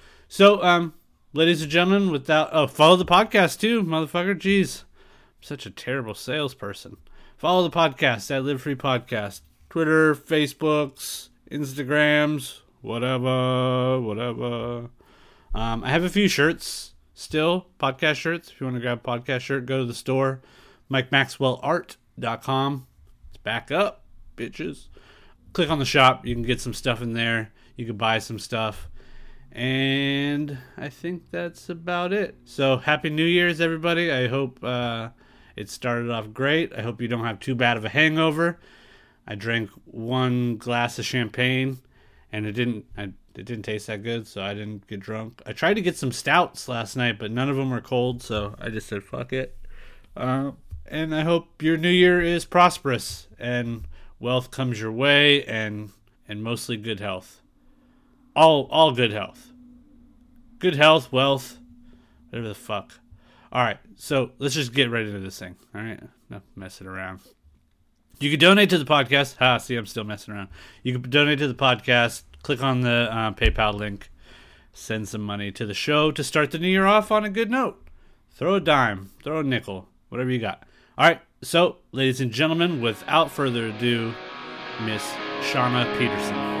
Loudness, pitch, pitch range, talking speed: -23 LUFS, 130 Hz, 115-155 Hz, 170 wpm